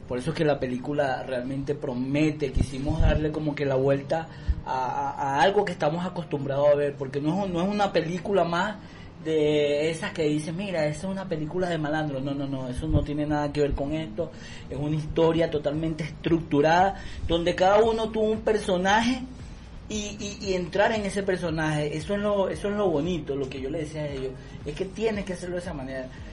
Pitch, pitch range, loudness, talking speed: 155 Hz, 145-190 Hz, -26 LUFS, 210 wpm